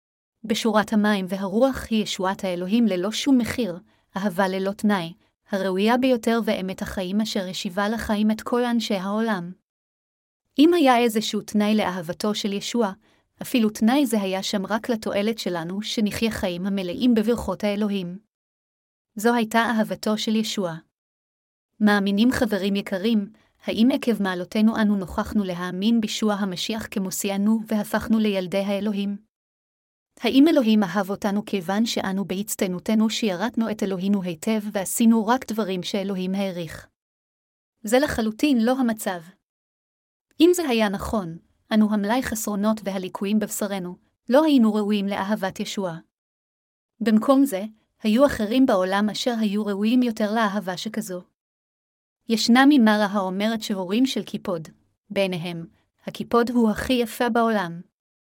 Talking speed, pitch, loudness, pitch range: 125 wpm, 210 Hz, -23 LUFS, 195-230 Hz